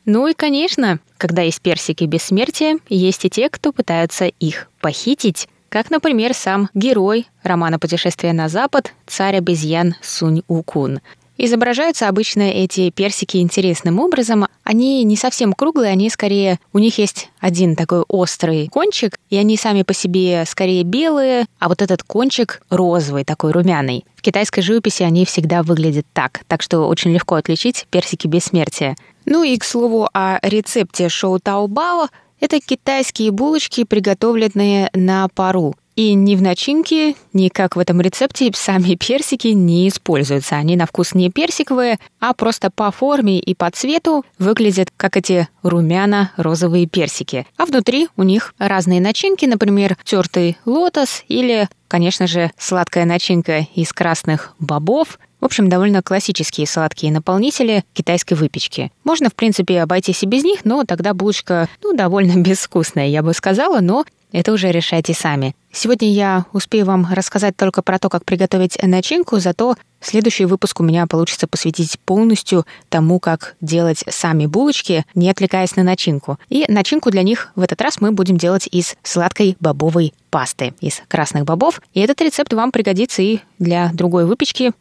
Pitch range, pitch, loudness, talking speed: 175-220 Hz, 190 Hz, -16 LUFS, 155 wpm